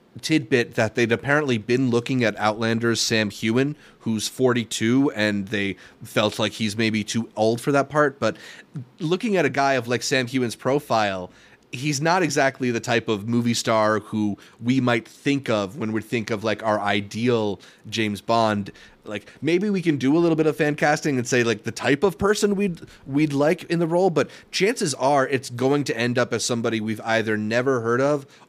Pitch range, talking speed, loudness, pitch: 110-140 Hz, 200 wpm, -22 LUFS, 120 Hz